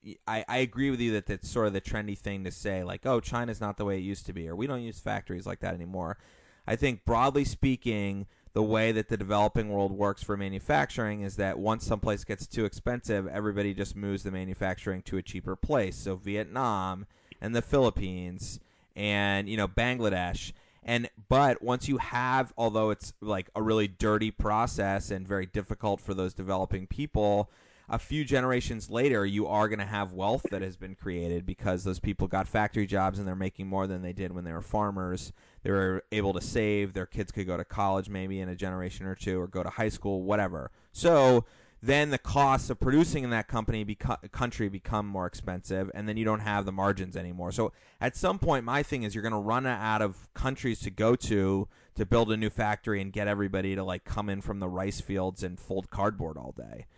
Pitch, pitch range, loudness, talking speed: 105 Hz, 95-110 Hz, -30 LUFS, 215 wpm